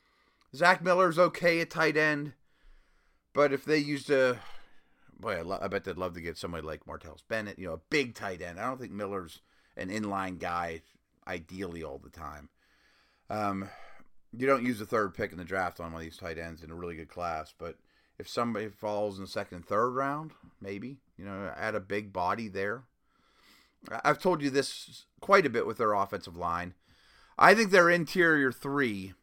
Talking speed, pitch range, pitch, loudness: 195 wpm, 90-145 Hz, 105 Hz, -30 LUFS